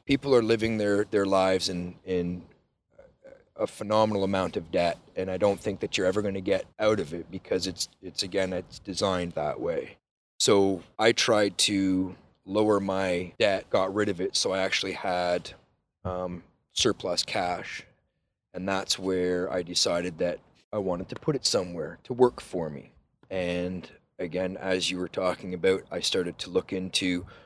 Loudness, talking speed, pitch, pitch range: -28 LUFS, 175 wpm, 95 Hz, 90-100 Hz